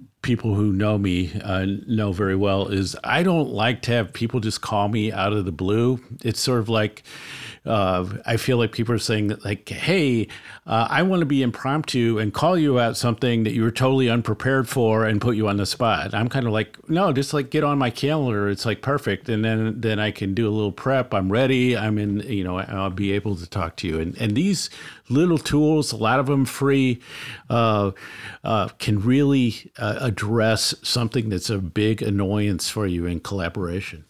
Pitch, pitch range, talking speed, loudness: 110 Hz, 100-130 Hz, 210 wpm, -22 LUFS